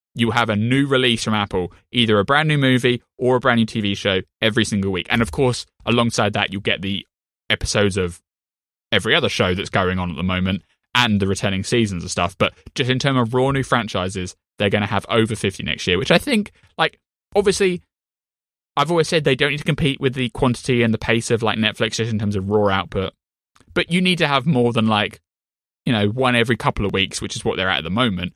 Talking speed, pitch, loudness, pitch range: 240 wpm, 110 Hz, -19 LUFS, 100-125 Hz